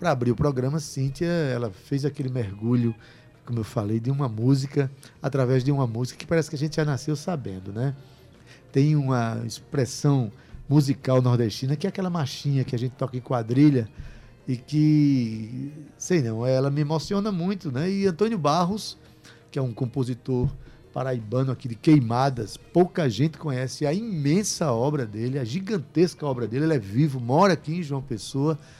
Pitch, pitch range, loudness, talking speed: 135 Hz, 125-155 Hz, -25 LUFS, 170 wpm